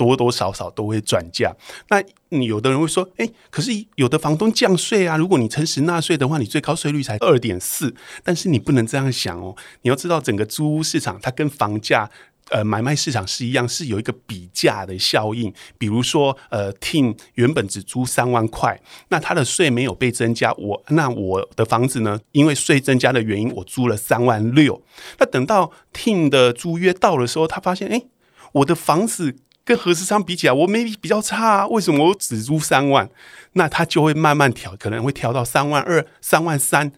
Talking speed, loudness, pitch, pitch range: 300 characters per minute, -19 LUFS, 140 Hz, 115-165 Hz